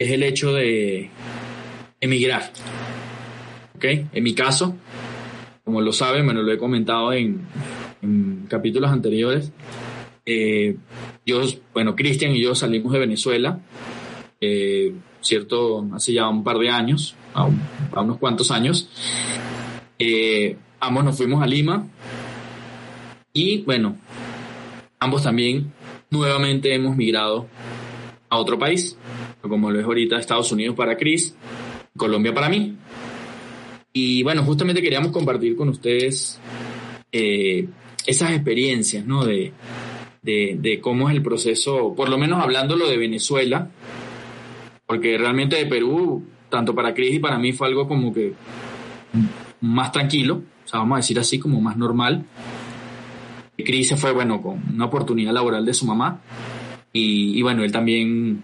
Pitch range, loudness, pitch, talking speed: 115-140 Hz, -20 LUFS, 125 Hz, 135 wpm